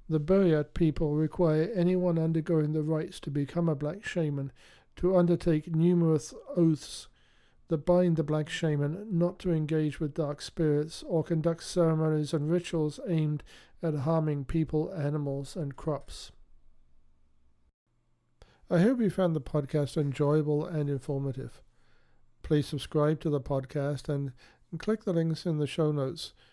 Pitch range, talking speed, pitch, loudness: 145-170 Hz, 140 wpm, 155 Hz, -29 LUFS